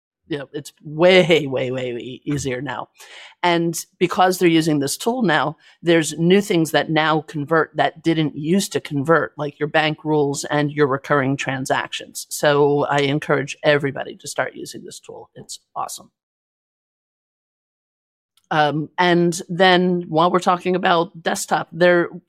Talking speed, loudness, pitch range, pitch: 150 wpm, -19 LUFS, 145-175 Hz, 155 Hz